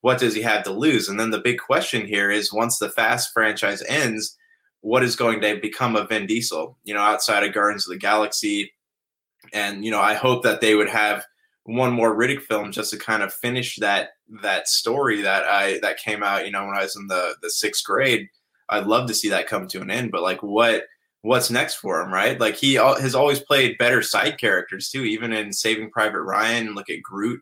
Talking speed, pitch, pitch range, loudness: 230 wpm, 110 Hz, 105-125 Hz, -21 LUFS